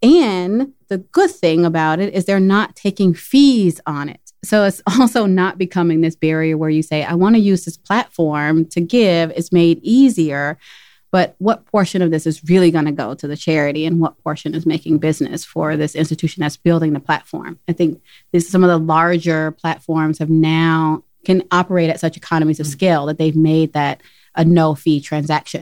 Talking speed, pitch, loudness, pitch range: 200 wpm, 165 Hz, -16 LUFS, 155-185 Hz